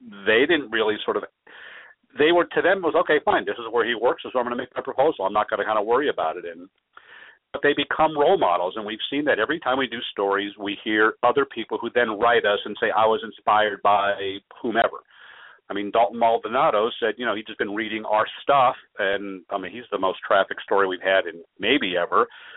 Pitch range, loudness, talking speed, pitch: 100-120 Hz, -22 LUFS, 235 wpm, 110 Hz